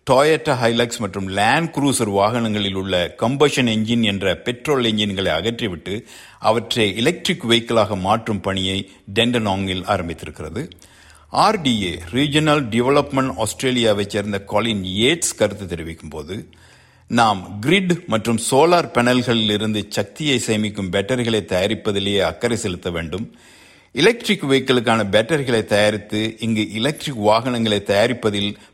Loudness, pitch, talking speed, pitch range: -19 LUFS, 110 Hz, 105 wpm, 100-125 Hz